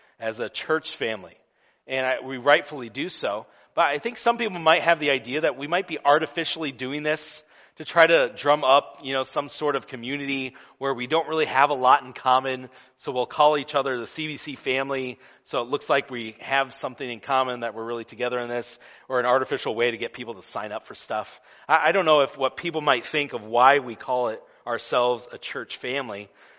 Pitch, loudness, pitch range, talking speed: 135 Hz, -24 LUFS, 125-155 Hz, 225 wpm